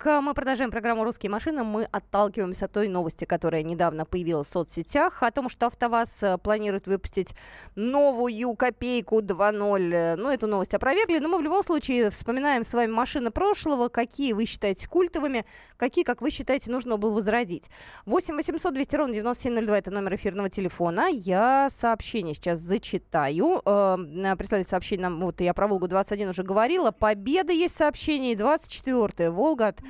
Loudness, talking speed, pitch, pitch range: -26 LUFS, 155 wpm, 225 Hz, 195-270 Hz